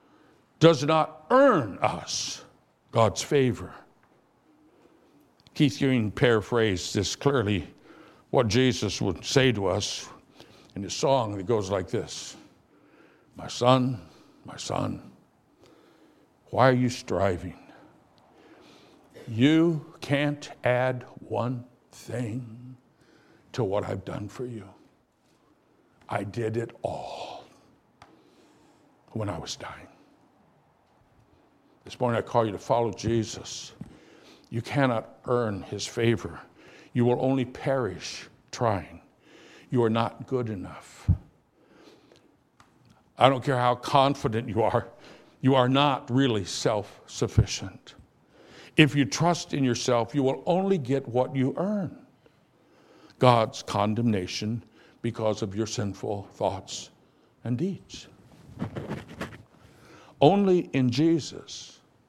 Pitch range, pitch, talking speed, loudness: 110-140 Hz, 125 Hz, 105 wpm, -26 LUFS